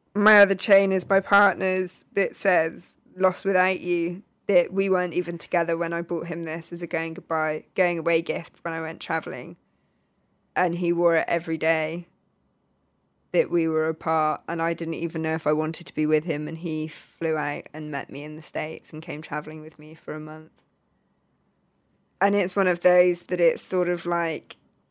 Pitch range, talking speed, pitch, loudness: 155-180 Hz, 200 wpm, 170 Hz, -24 LUFS